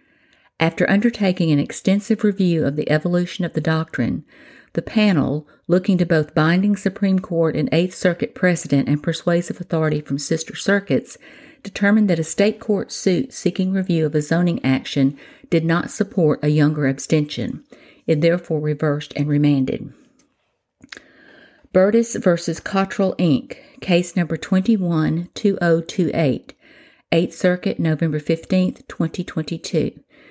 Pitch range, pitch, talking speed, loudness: 155-195 Hz, 175 Hz, 125 wpm, -20 LUFS